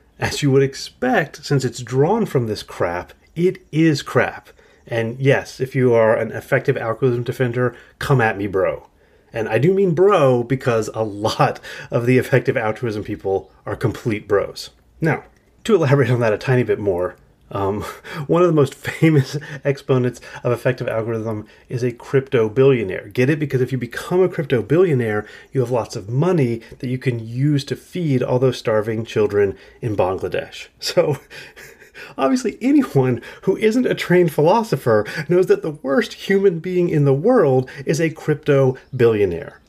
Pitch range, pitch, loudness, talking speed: 120-155 Hz, 135 Hz, -19 LUFS, 170 wpm